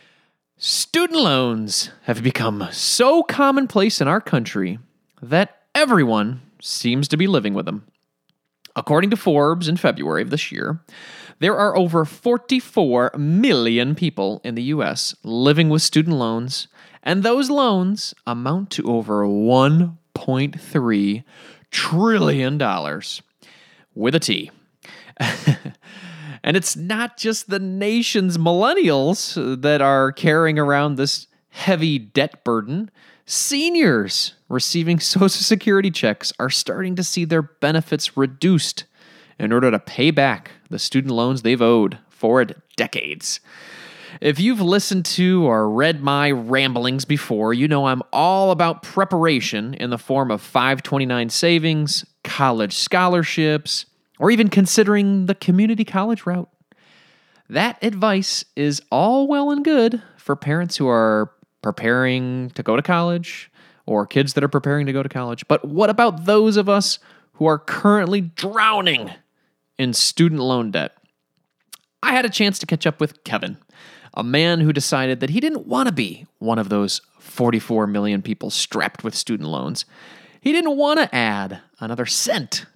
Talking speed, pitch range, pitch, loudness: 140 wpm, 130-195 Hz, 160 Hz, -19 LUFS